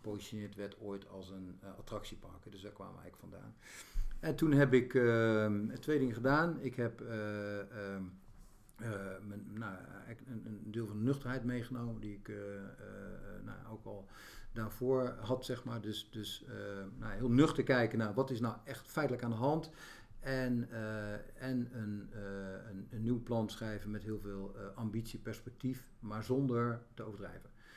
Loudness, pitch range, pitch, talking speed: -38 LUFS, 100-125 Hz, 110 Hz, 175 wpm